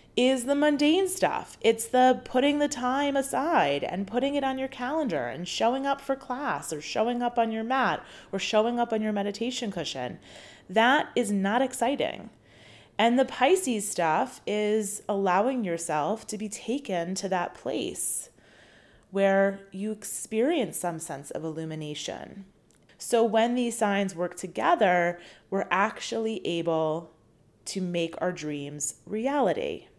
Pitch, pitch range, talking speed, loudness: 215 Hz, 180-250 Hz, 145 wpm, -27 LUFS